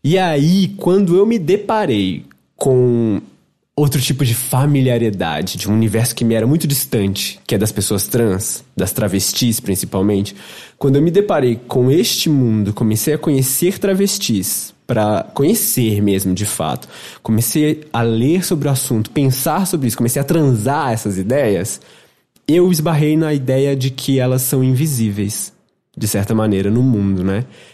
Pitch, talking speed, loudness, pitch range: 125 Hz, 155 wpm, -16 LUFS, 105-150 Hz